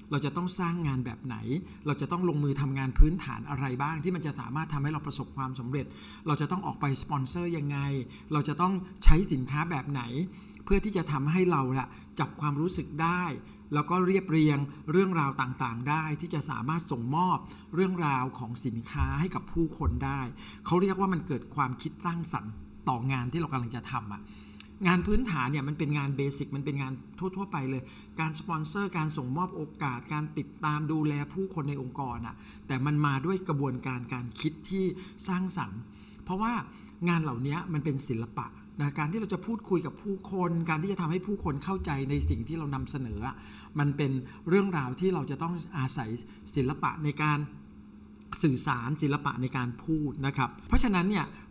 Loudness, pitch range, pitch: -31 LUFS, 130-175 Hz, 150 Hz